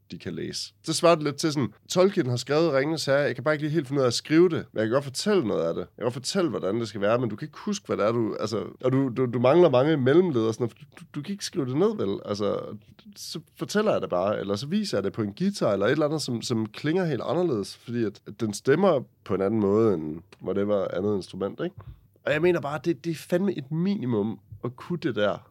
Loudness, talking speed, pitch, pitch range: -26 LUFS, 290 wpm, 145 Hz, 115-170 Hz